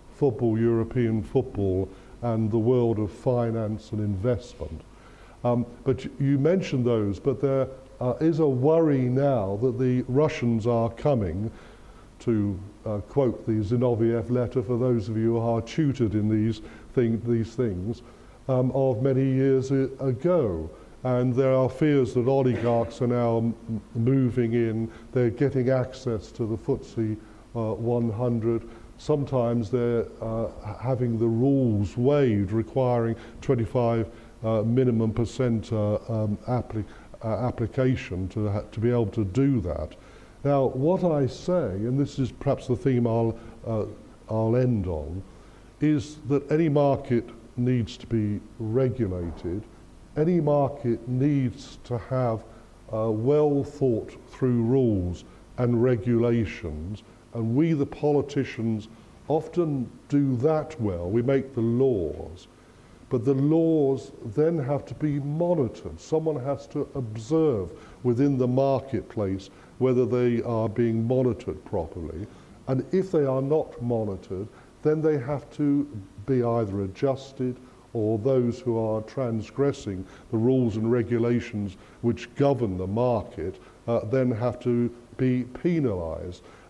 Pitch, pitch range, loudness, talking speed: 120 Hz, 110-135 Hz, -26 LUFS, 135 wpm